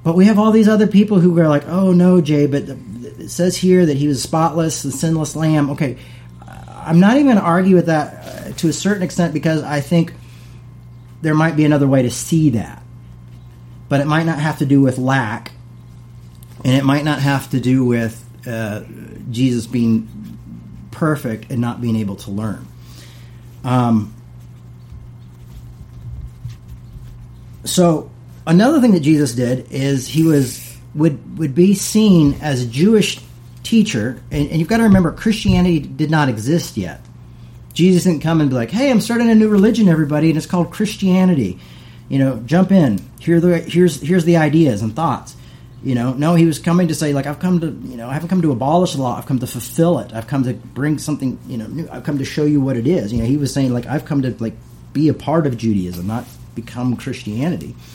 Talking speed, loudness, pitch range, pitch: 205 wpm, -16 LUFS, 120-165 Hz, 140 Hz